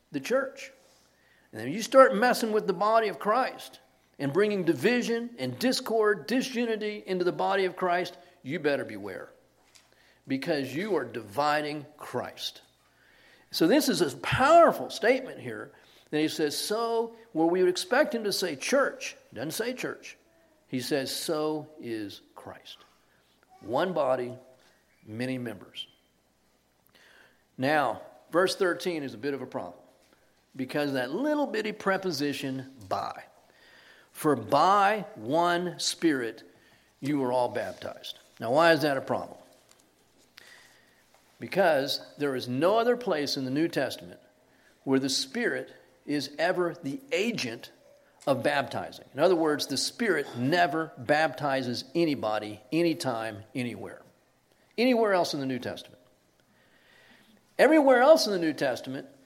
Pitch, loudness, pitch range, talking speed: 160 Hz, -27 LUFS, 130-210 Hz, 135 wpm